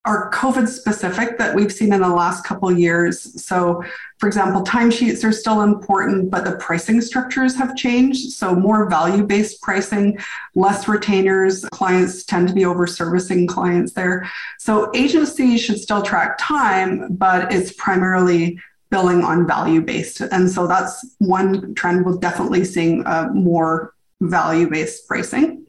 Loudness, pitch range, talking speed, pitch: -18 LUFS, 180-220 Hz, 155 wpm, 190 Hz